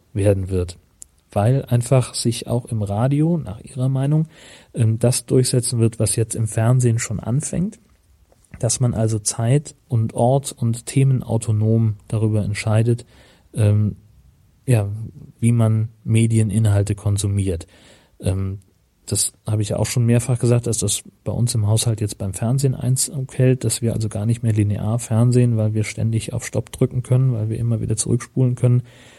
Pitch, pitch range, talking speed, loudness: 115 Hz, 105-125 Hz, 155 wpm, -20 LUFS